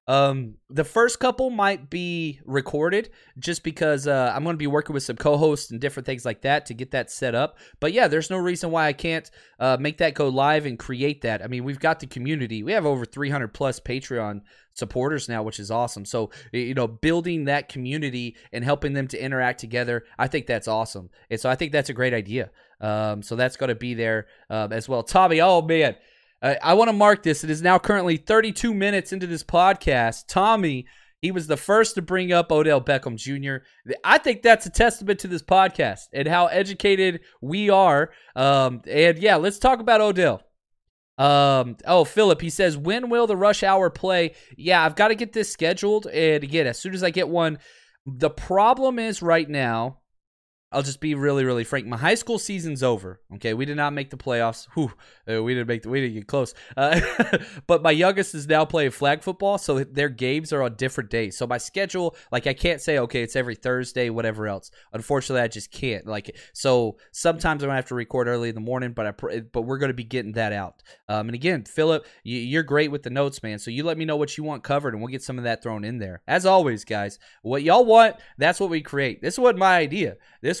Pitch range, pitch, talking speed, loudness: 120-175 Hz, 140 Hz, 220 wpm, -22 LUFS